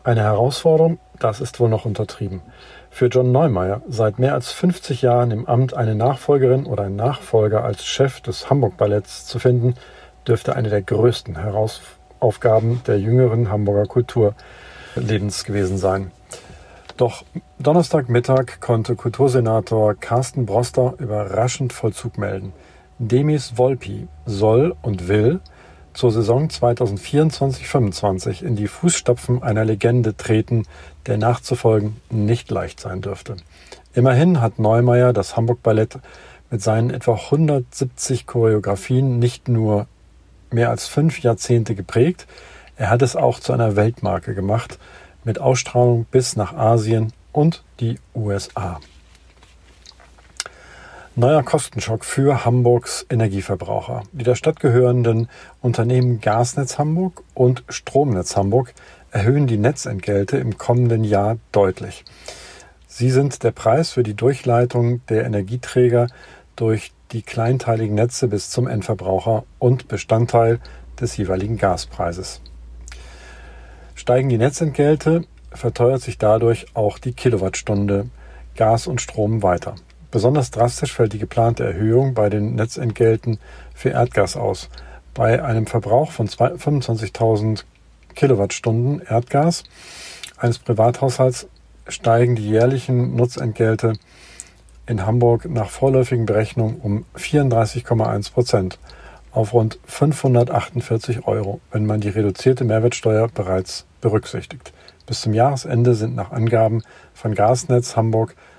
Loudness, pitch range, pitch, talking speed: -19 LUFS, 105-125 Hz, 115 Hz, 115 wpm